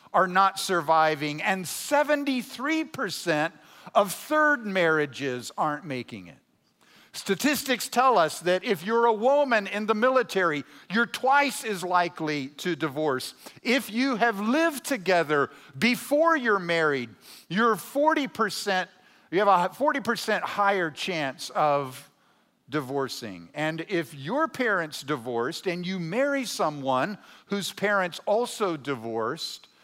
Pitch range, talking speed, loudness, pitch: 155-245 Hz, 120 wpm, -26 LUFS, 190 Hz